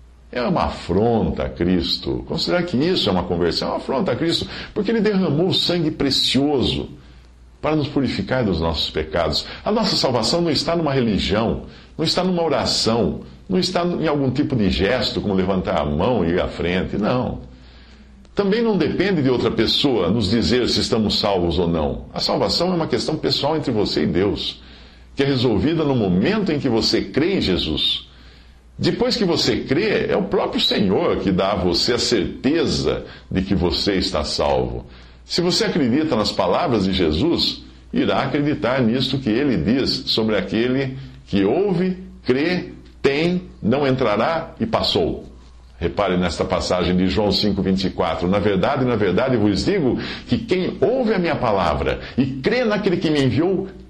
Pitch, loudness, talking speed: 110 Hz, -20 LUFS, 175 wpm